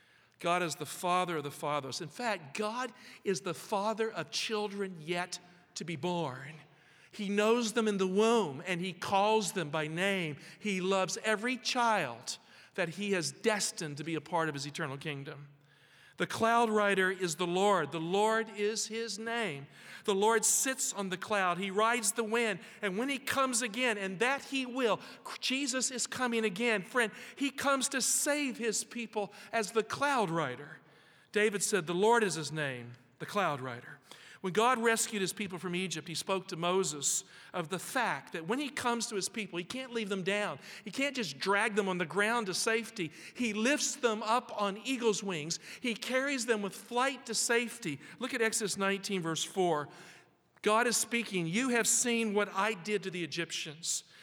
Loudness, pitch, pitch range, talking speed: -32 LUFS, 205 Hz, 175-230 Hz, 190 wpm